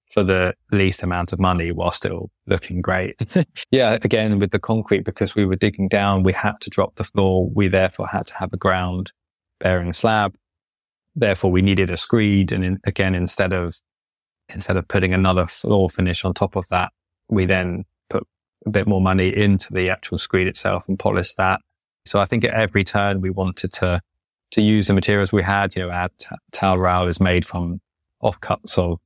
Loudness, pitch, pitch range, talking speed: -20 LUFS, 95 Hz, 90-100 Hz, 195 wpm